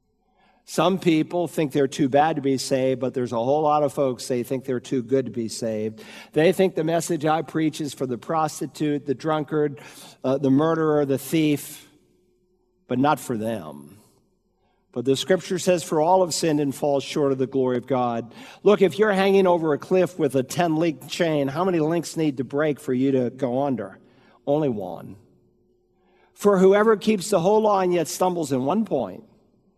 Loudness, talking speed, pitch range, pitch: -22 LUFS, 195 wpm, 135-175 Hz, 150 Hz